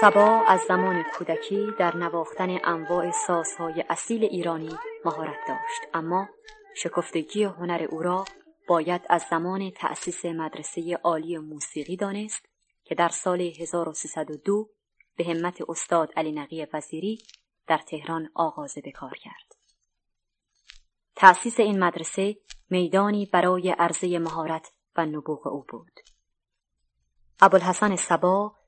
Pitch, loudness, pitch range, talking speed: 175 Hz, -25 LUFS, 165-205 Hz, 110 wpm